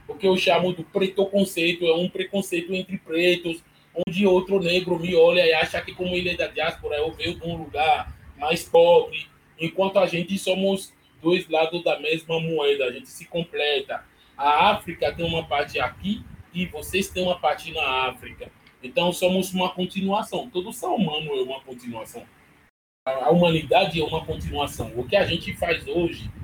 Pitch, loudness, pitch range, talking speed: 175 Hz, -23 LUFS, 160-190 Hz, 175 wpm